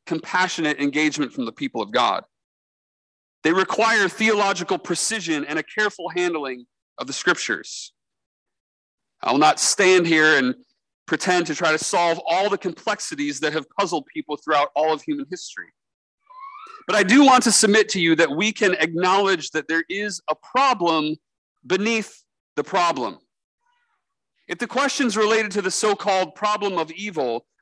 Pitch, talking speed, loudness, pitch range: 190 Hz, 155 wpm, -20 LUFS, 160-225 Hz